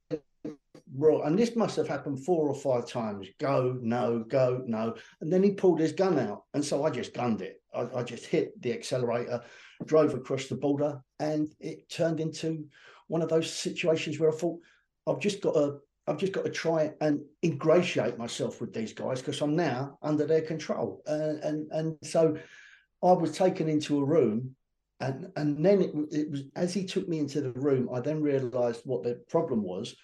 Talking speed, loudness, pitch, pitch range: 195 wpm, -29 LUFS, 150 Hz, 135-165 Hz